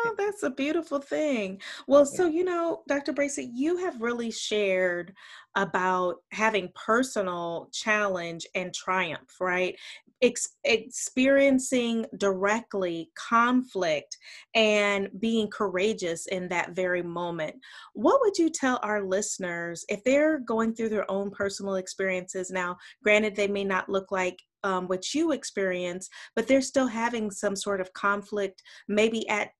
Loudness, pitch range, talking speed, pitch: -27 LUFS, 185-245 Hz, 135 wpm, 205 Hz